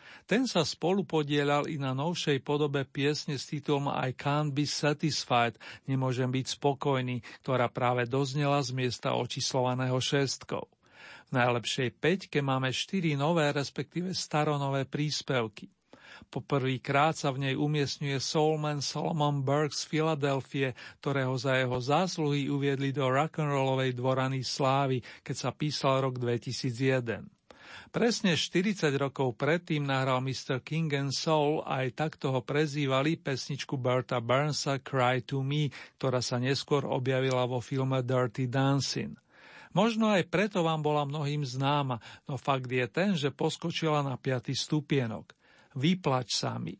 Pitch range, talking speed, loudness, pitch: 130-150 Hz, 135 wpm, -30 LUFS, 140 Hz